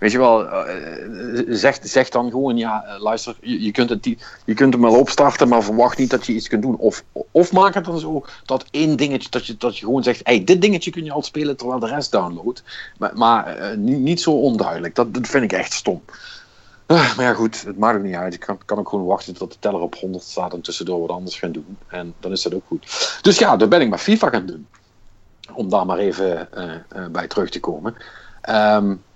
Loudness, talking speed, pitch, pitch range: -18 LUFS, 240 wpm, 125 Hz, 110-150 Hz